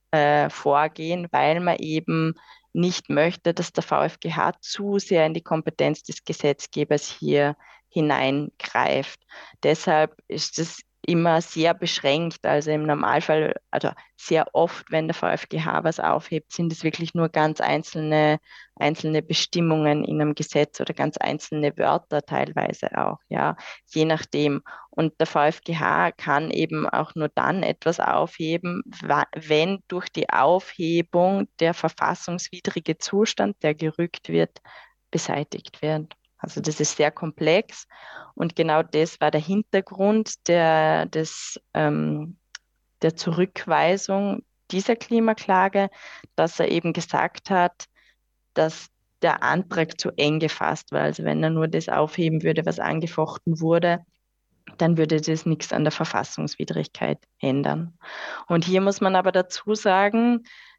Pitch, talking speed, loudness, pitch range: 160 Hz, 130 wpm, -23 LUFS, 155-175 Hz